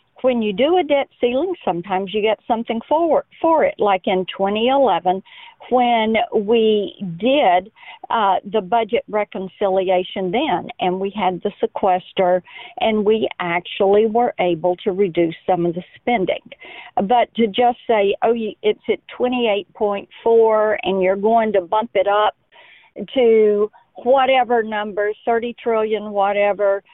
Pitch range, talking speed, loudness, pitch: 195-235 Hz, 135 wpm, -18 LUFS, 215 Hz